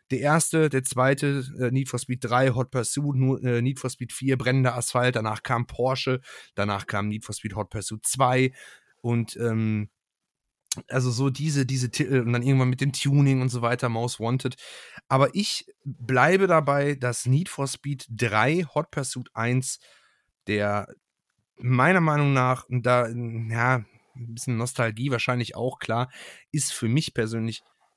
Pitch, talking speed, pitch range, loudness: 125 Hz, 160 wpm, 120-135 Hz, -25 LUFS